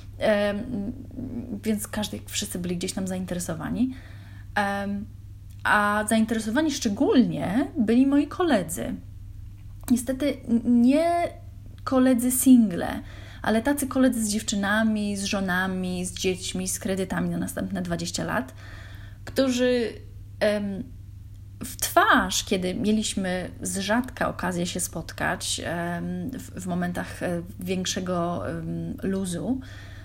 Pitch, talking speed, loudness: 190 Hz, 105 wpm, -25 LUFS